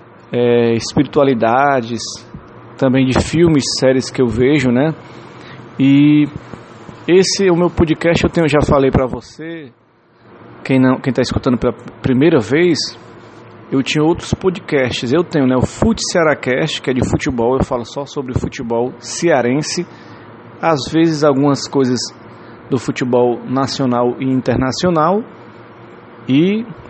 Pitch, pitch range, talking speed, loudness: 130 Hz, 120-150 Hz, 130 wpm, -15 LUFS